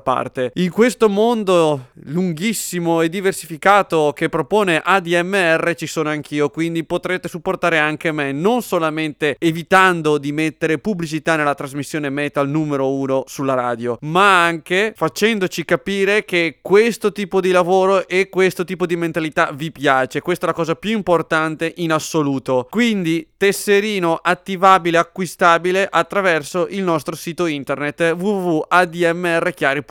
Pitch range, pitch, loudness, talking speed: 155-185 Hz, 170 Hz, -17 LUFS, 130 wpm